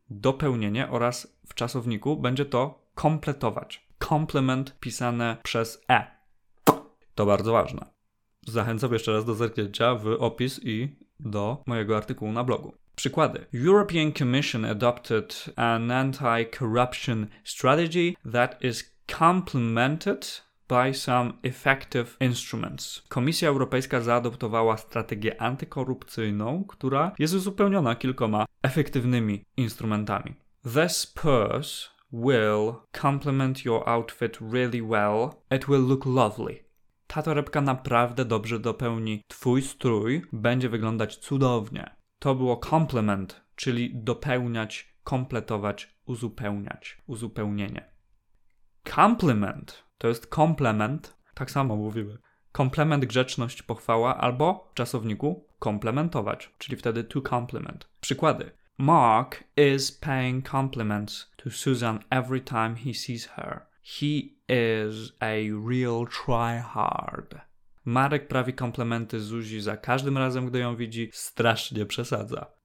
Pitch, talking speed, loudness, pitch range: 120 Hz, 105 wpm, -27 LUFS, 115-135 Hz